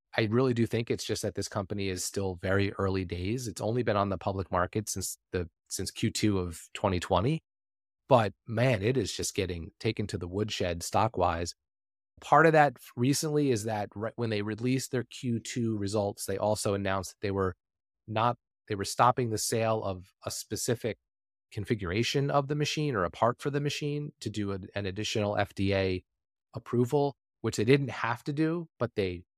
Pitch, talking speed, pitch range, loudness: 105 Hz, 190 wpm, 95-120 Hz, -30 LUFS